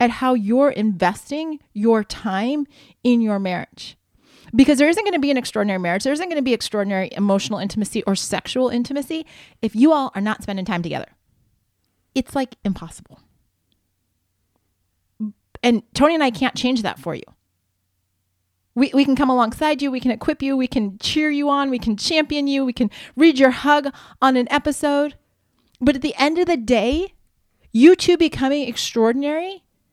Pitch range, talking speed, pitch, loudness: 195-285 Hz, 170 wpm, 245 Hz, -19 LUFS